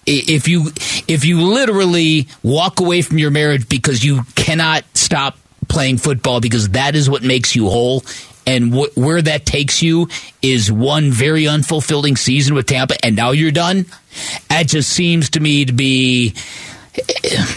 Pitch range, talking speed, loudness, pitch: 130-160 Hz, 160 wpm, -14 LUFS, 145 Hz